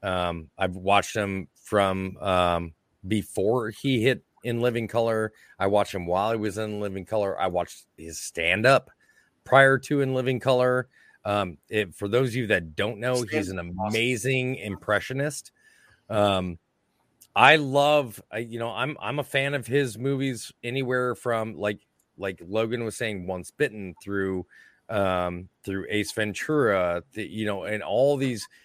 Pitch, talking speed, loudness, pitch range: 110 Hz, 160 wpm, -26 LUFS, 95-125 Hz